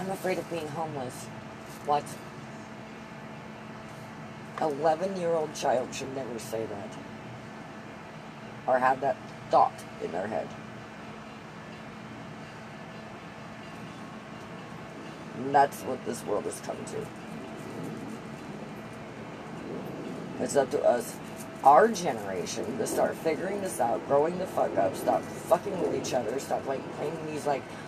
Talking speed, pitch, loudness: 115 wpm, 135 Hz, -30 LUFS